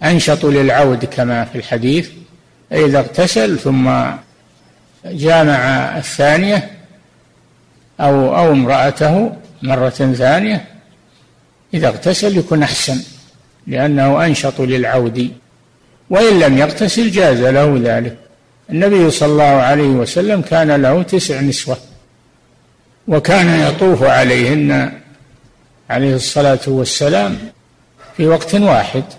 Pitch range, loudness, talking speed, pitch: 130-170 Hz, -13 LUFS, 95 wpm, 145 Hz